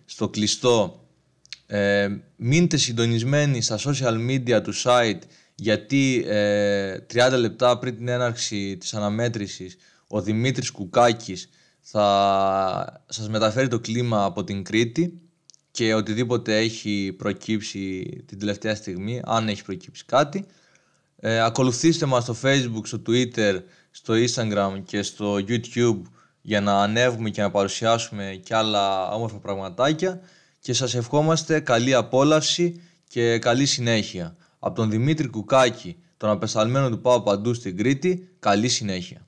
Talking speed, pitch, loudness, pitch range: 130 wpm, 115 Hz, -23 LUFS, 105-130 Hz